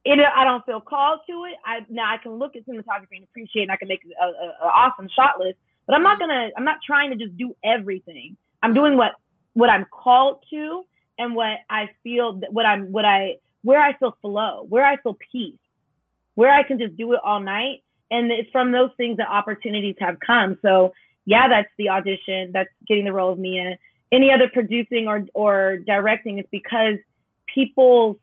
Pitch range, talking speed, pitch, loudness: 200-255 Hz, 205 wpm, 225 Hz, -20 LUFS